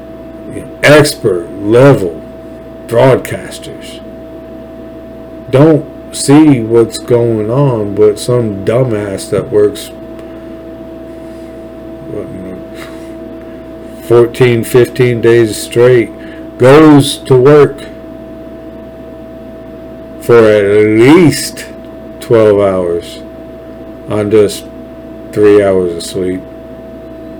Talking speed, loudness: 70 wpm, -9 LUFS